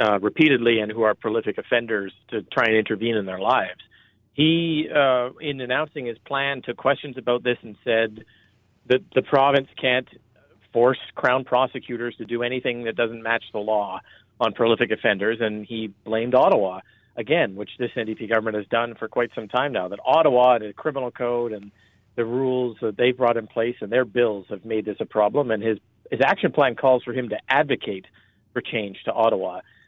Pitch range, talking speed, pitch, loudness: 110-125 Hz, 195 wpm, 120 Hz, -23 LUFS